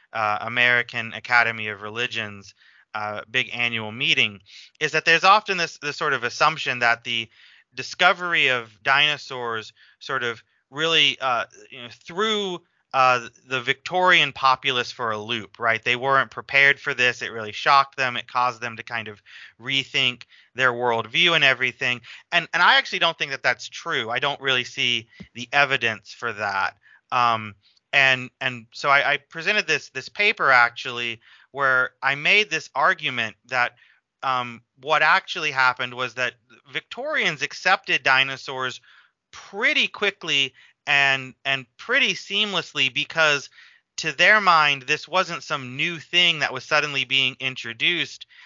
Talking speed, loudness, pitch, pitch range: 150 wpm, -21 LUFS, 130 Hz, 120-150 Hz